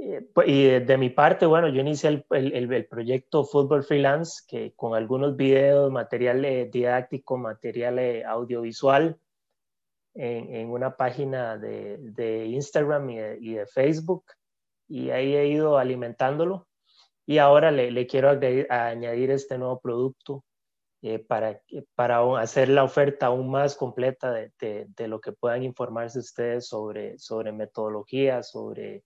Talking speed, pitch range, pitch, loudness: 145 wpm, 120-140 Hz, 130 Hz, -24 LUFS